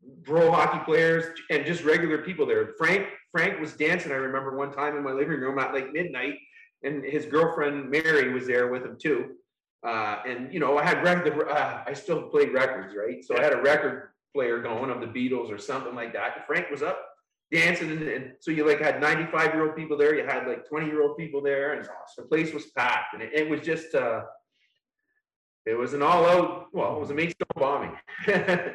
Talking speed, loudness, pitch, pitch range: 205 wpm, -26 LUFS, 155 Hz, 140-165 Hz